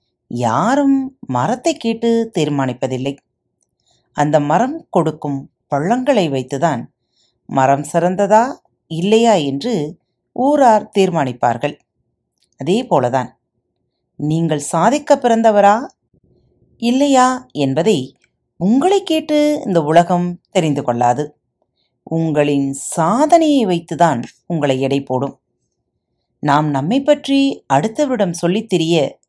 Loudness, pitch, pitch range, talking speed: -16 LUFS, 170 Hz, 140-235 Hz, 80 wpm